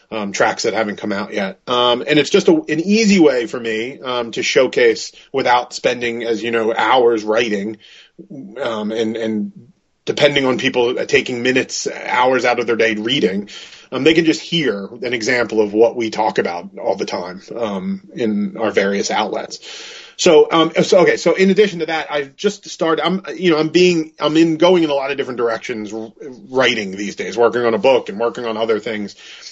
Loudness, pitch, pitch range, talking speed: -16 LUFS, 125 Hz, 115-165 Hz, 200 wpm